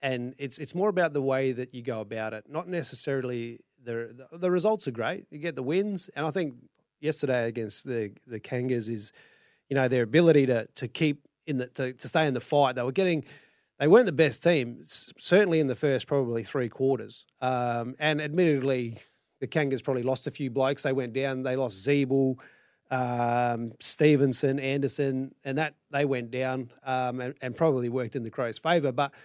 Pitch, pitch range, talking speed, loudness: 135 Hz, 125-150 Hz, 200 wpm, -28 LUFS